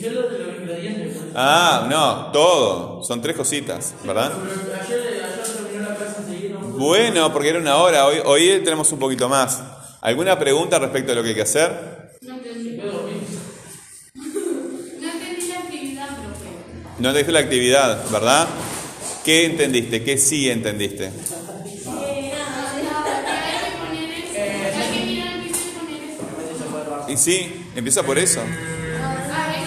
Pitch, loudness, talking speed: 190 Hz, -20 LUFS, 85 wpm